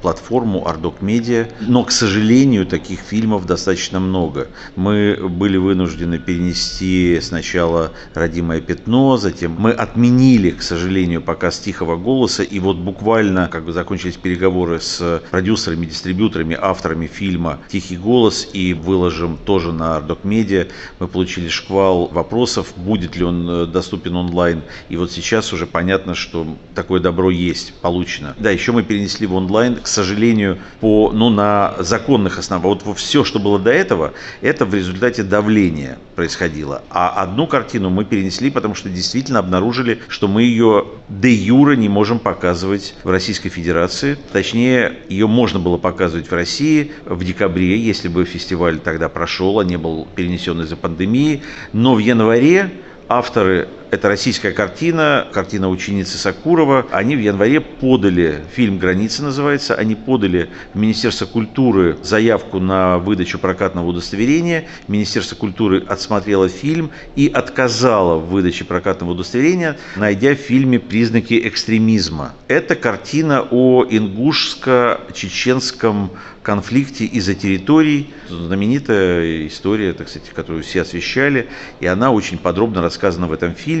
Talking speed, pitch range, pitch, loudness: 140 wpm, 90-115 Hz, 95 Hz, -16 LUFS